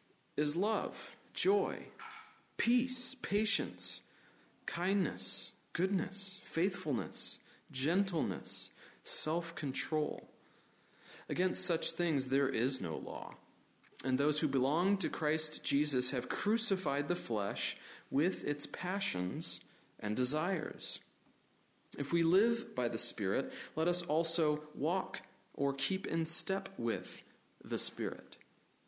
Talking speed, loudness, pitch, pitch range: 105 wpm, -35 LUFS, 170 Hz, 145-195 Hz